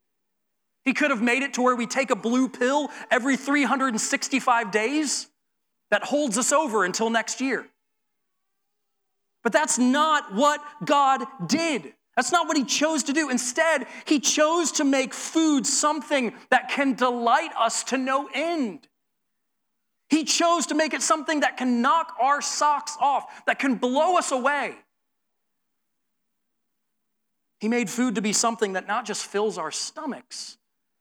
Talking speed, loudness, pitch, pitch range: 150 wpm, -23 LUFS, 265 Hz, 235-295 Hz